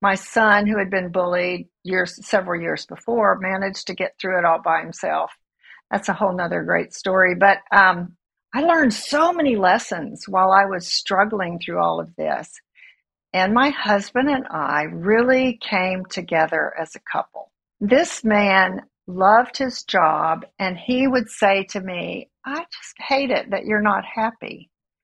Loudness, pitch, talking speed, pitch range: -20 LUFS, 195 Hz, 165 wpm, 185-230 Hz